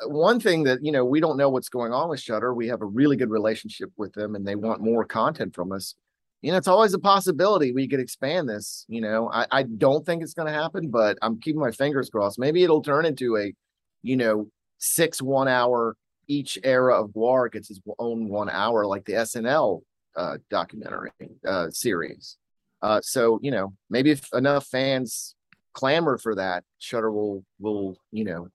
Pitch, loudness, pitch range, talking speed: 125 Hz, -24 LUFS, 110-140 Hz, 200 wpm